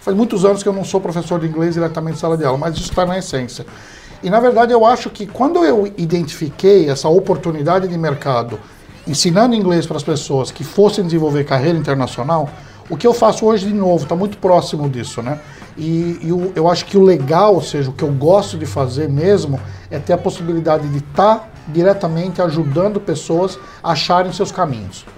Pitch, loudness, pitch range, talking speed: 170 Hz, -15 LUFS, 150-195 Hz, 205 wpm